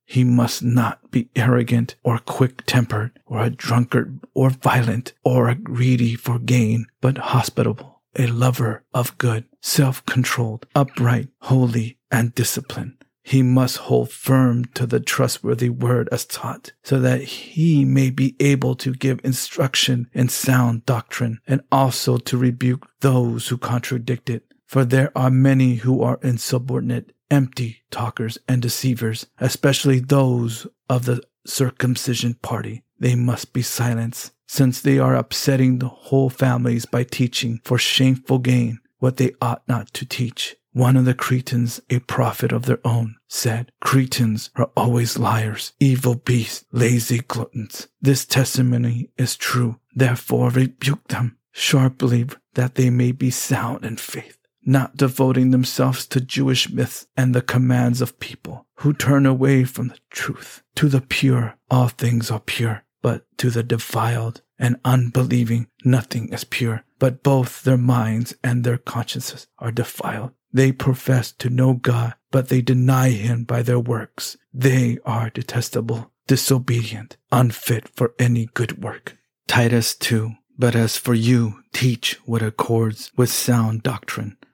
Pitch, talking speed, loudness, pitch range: 125 Hz, 145 wpm, -20 LUFS, 120-130 Hz